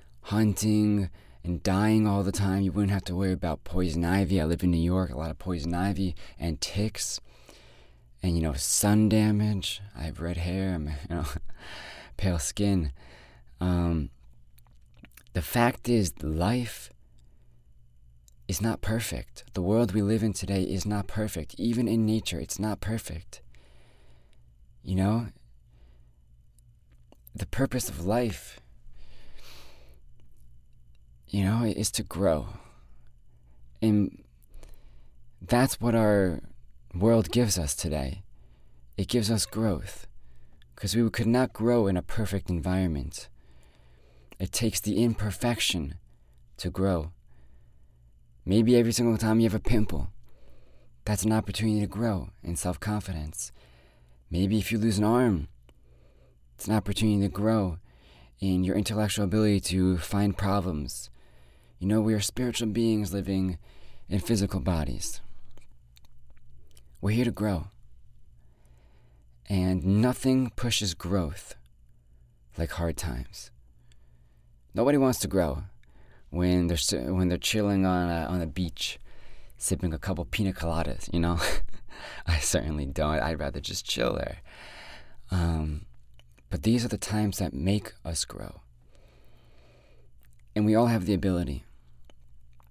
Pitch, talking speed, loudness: 90 Hz, 130 wpm, -28 LUFS